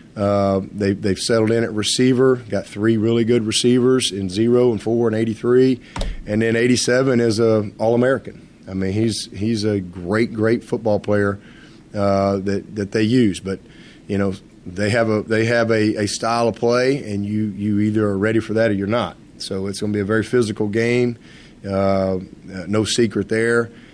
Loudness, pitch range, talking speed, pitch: -19 LUFS, 100-115 Hz, 190 wpm, 110 Hz